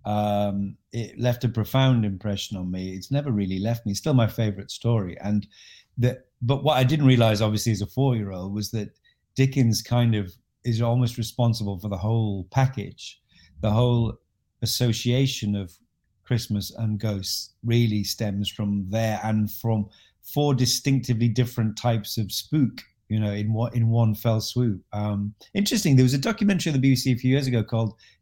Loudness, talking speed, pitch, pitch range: -24 LUFS, 180 wpm, 115 Hz, 105-125 Hz